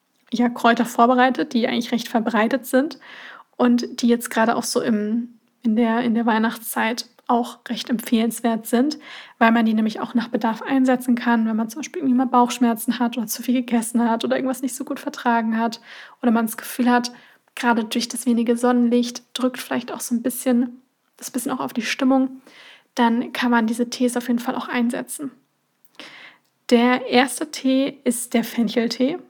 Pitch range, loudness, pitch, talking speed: 235-255 Hz, -21 LUFS, 245 Hz, 185 wpm